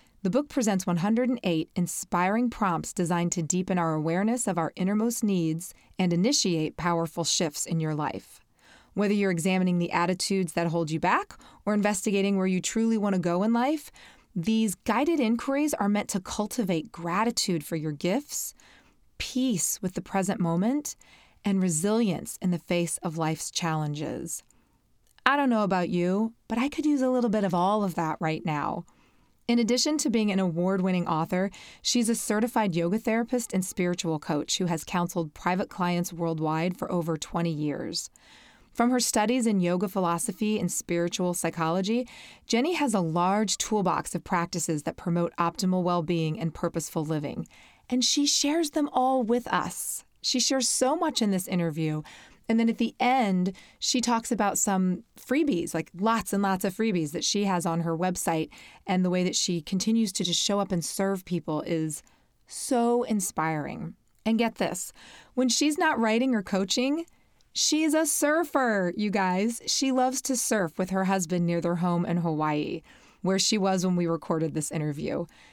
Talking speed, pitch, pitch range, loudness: 175 wpm, 190 Hz, 170-230 Hz, -27 LUFS